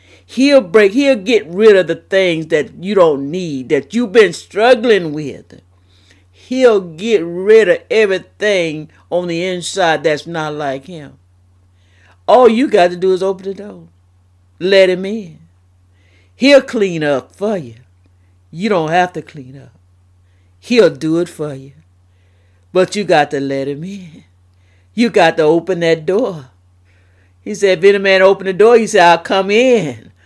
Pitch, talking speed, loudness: 165 Hz, 165 wpm, -13 LUFS